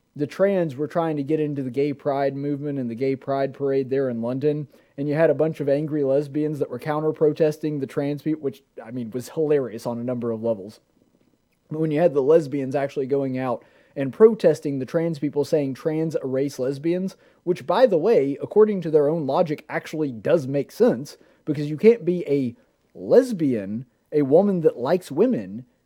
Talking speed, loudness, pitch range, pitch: 200 wpm, -23 LUFS, 135-155 Hz, 145 Hz